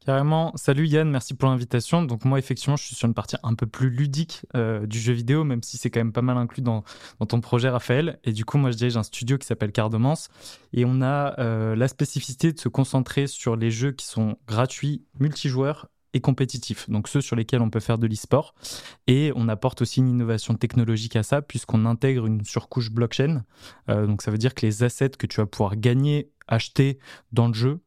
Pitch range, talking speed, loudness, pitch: 115-135 Hz, 225 wpm, -24 LUFS, 125 Hz